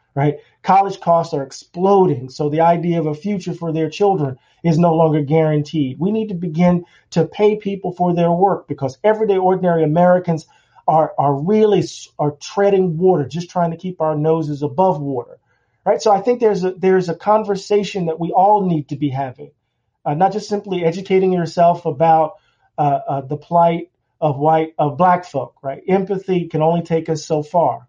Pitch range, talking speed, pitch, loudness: 155-190 Hz, 185 wpm, 170 Hz, -17 LUFS